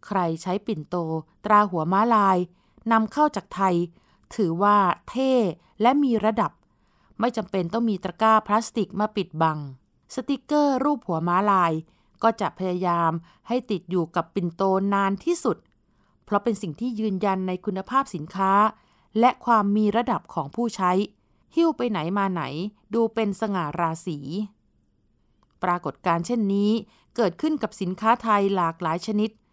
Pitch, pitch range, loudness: 200 Hz, 175-225 Hz, -24 LUFS